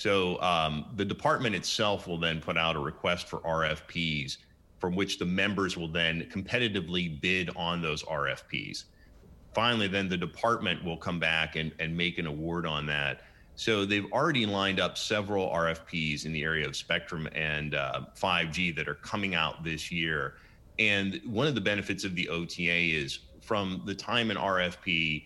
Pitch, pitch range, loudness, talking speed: 85 Hz, 80-95 Hz, -30 LUFS, 175 wpm